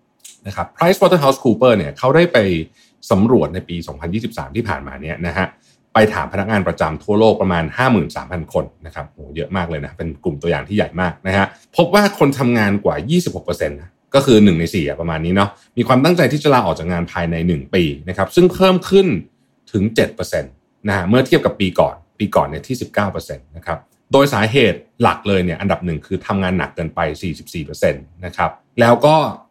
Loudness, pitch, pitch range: -16 LUFS, 100 Hz, 85-130 Hz